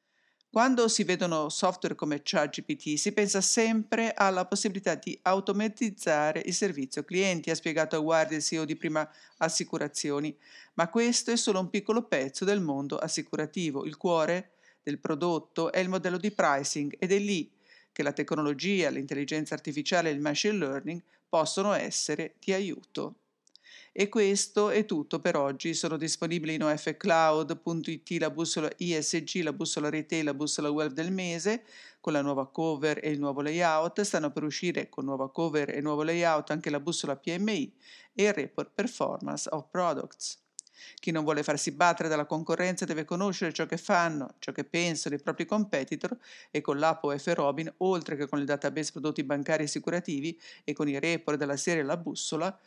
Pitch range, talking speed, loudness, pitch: 150-185 Hz, 170 wpm, -30 LUFS, 165 Hz